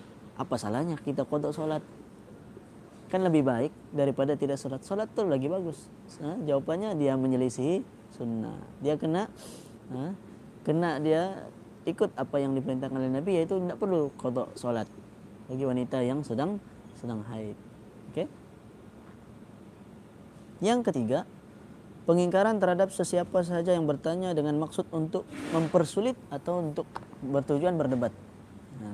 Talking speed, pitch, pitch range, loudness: 125 wpm, 150 Hz, 130-175 Hz, -30 LUFS